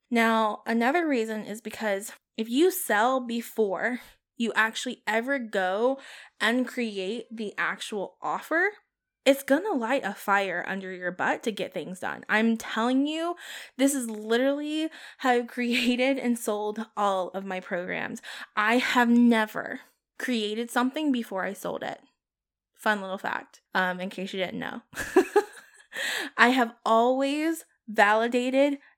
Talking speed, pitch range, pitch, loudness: 140 wpm, 210-265 Hz, 235 Hz, -27 LUFS